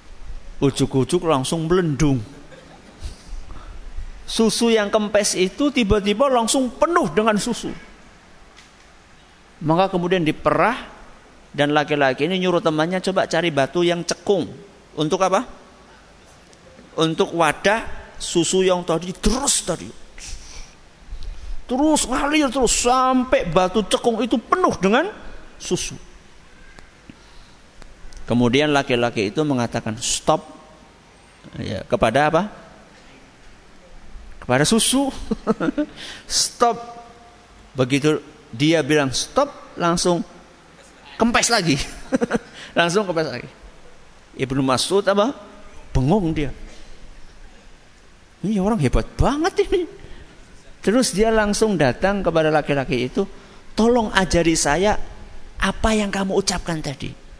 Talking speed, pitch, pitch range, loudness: 95 wpm, 185 Hz, 150-225 Hz, -20 LUFS